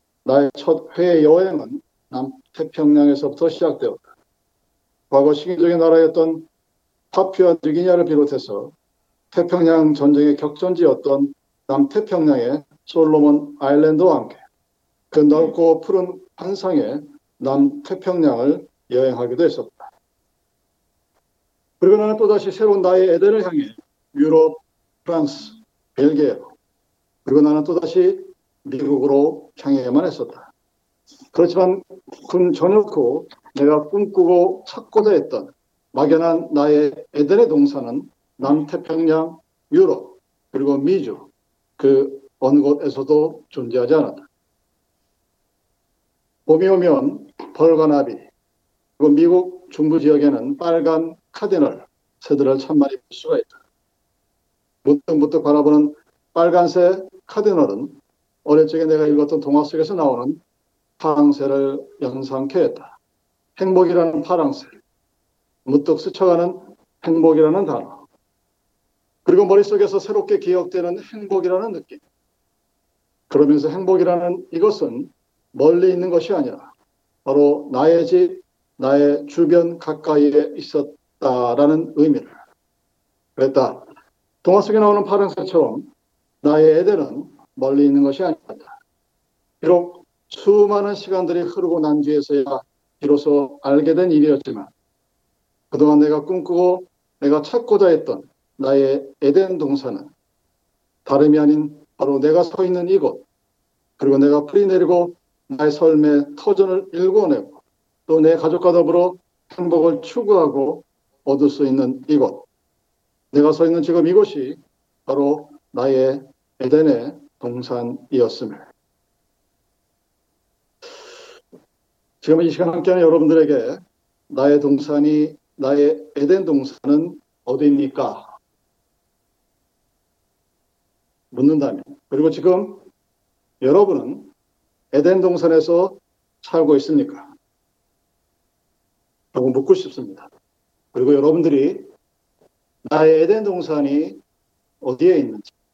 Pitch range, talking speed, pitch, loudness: 145-190 Hz, 245 characters per minute, 160 Hz, -17 LUFS